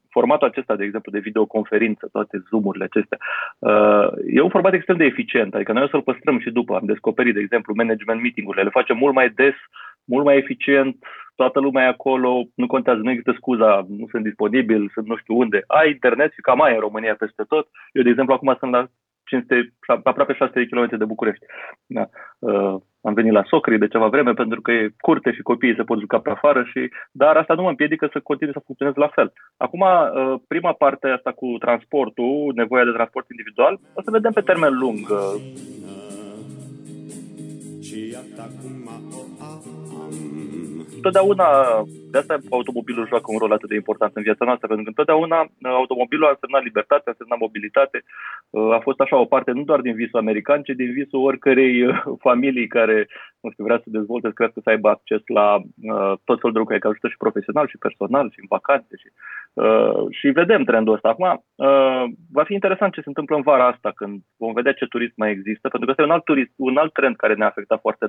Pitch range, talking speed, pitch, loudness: 110-135 Hz, 195 wpm, 125 Hz, -19 LUFS